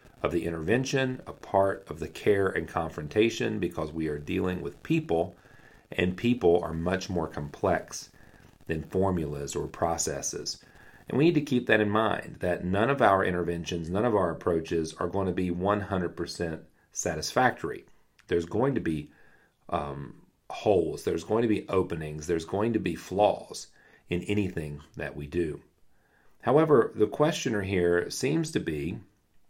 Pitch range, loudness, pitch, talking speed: 80-105 Hz, -28 LUFS, 90 Hz, 155 wpm